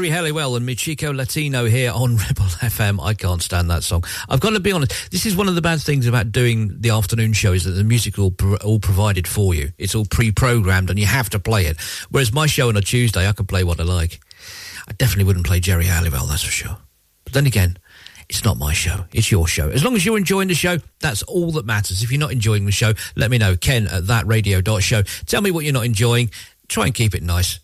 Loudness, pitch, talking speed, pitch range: -18 LUFS, 110 Hz, 250 wpm, 95-125 Hz